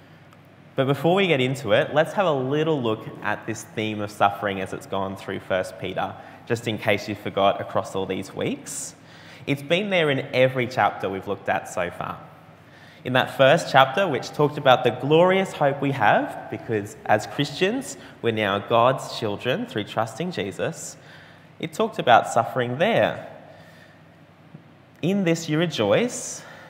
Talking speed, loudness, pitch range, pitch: 165 wpm, -23 LUFS, 105-155 Hz, 130 Hz